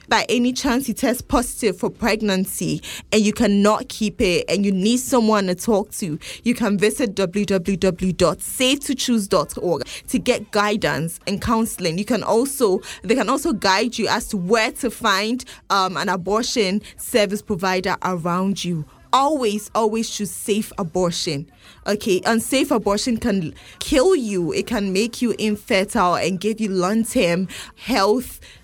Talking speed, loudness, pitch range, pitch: 145 wpm, -20 LUFS, 190-235 Hz, 210 Hz